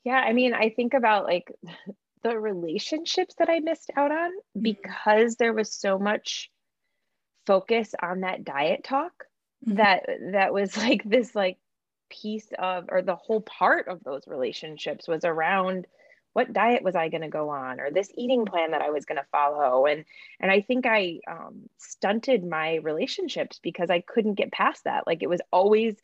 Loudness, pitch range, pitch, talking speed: -25 LUFS, 180-245 Hz, 210 Hz, 180 wpm